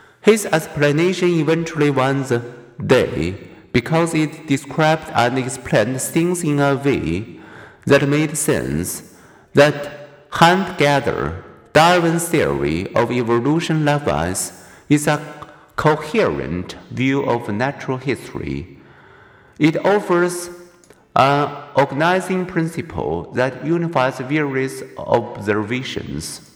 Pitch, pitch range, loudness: 145 Hz, 125-160 Hz, -18 LUFS